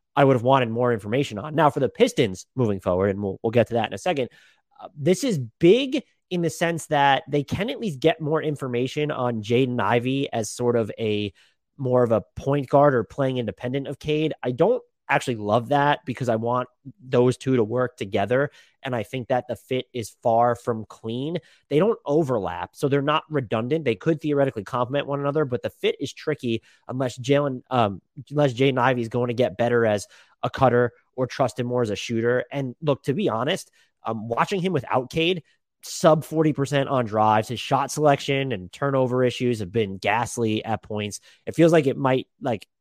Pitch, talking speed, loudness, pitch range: 130 Hz, 205 wpm, -23 LUFS, 120-145 Hz